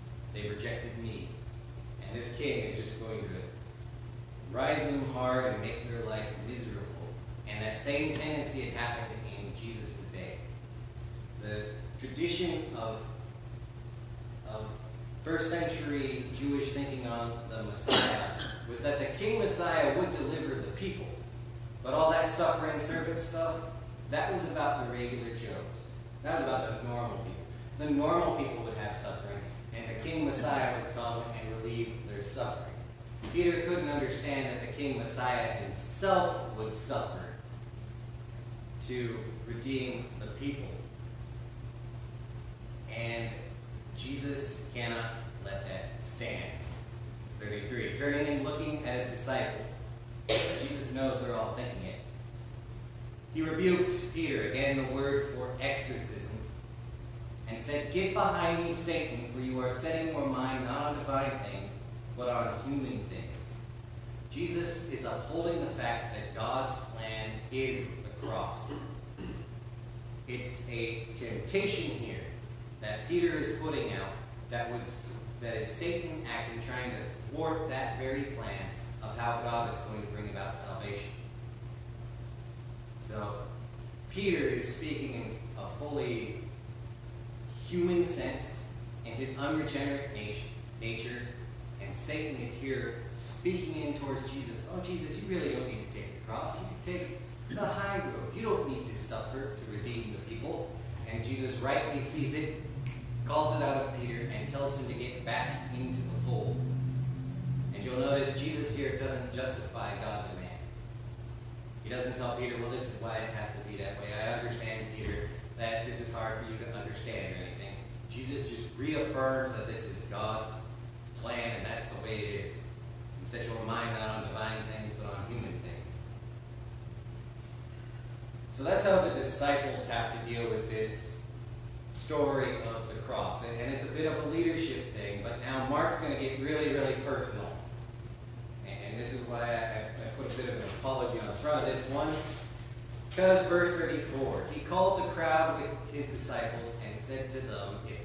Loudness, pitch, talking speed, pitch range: -35 LUFS, 120 Hz, 155 wpm, 115-130 Hz